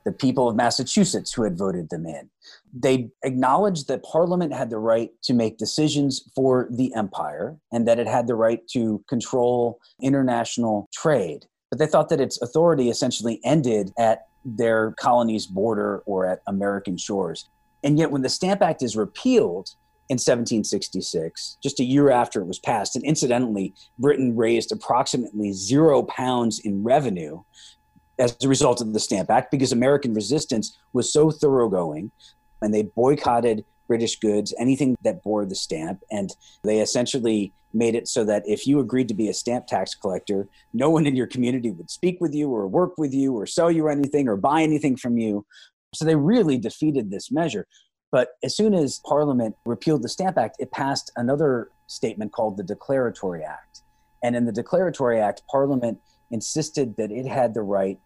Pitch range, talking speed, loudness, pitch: 110-140 Hz, 175 wpm, -23 LUFS, 125 Hz